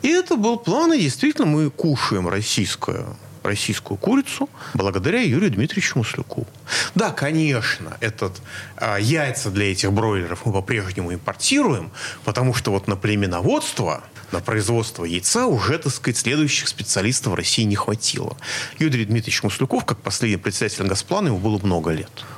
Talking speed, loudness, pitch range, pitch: 145 wpm, -21 LUFS, 100-140 Hz, 115 Hz